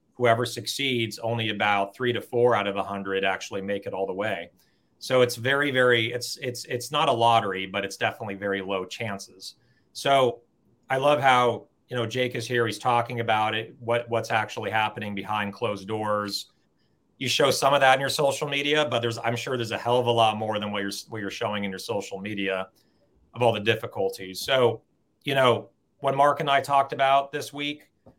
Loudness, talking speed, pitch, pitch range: -25 LUFS, 210 wpm, 115 Hz, 100-125 Hz